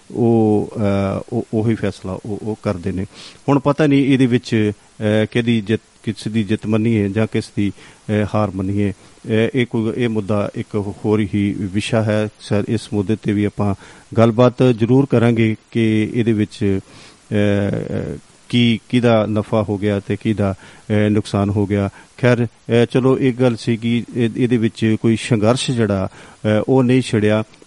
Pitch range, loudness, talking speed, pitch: 105-120 Hz, -18 LUFS, 150 wpm, 110 Hz